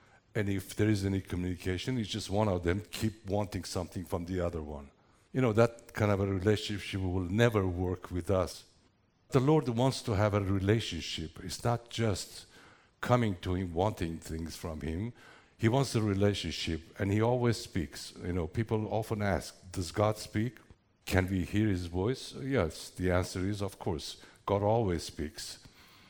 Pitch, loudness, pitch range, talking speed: 100 Hz, -32 LUFS, 90-110 Hz, 175 wpm